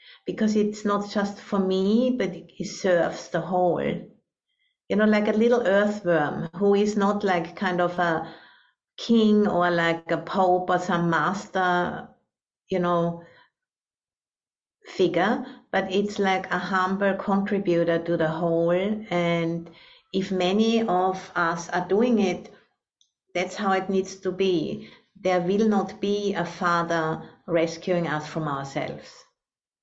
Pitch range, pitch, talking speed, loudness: 170-205 Hz, 185 Hz, 135 wpm, -24 LUFS